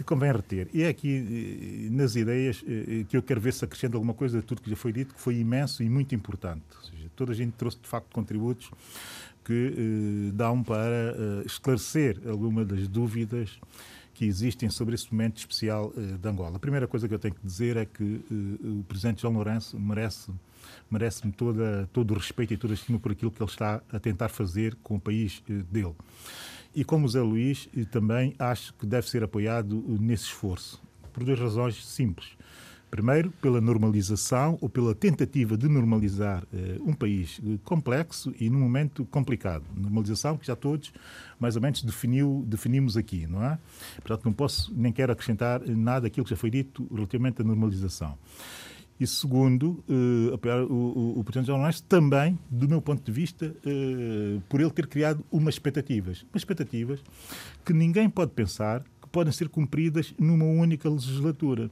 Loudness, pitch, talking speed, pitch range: -28 LUFS, 120 Hz, 185 wpm, 110-135 Hz